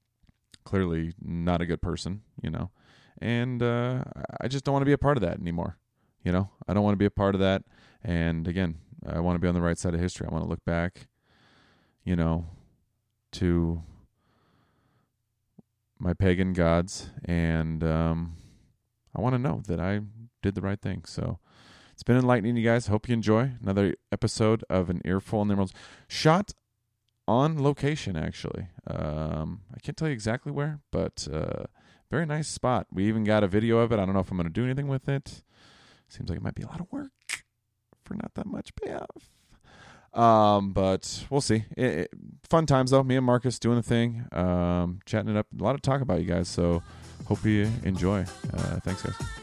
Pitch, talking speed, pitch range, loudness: 105 Hz, 200 wpm, 90-120 Hz, -28 LUFS